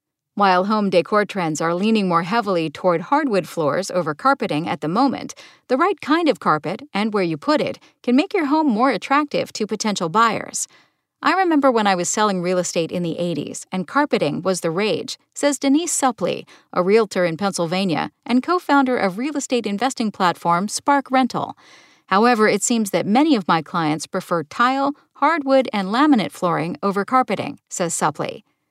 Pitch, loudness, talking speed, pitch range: 215 Hz, -20 LUFS, 180 wpm, 180-275 Hz